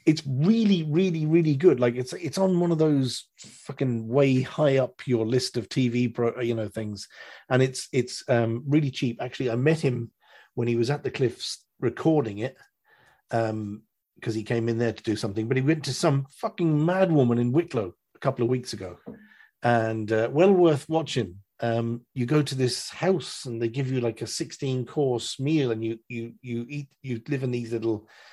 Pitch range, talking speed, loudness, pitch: 115-145 Hz, 205 wpm, -26 LUFS, 125 Hz